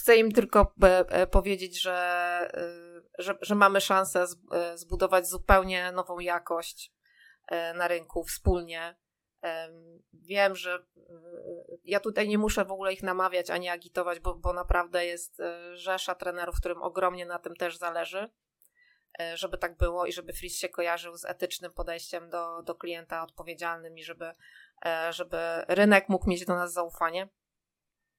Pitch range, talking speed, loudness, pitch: 170-190 Hz, 135 wpm, -29 LUFS, 175 Hz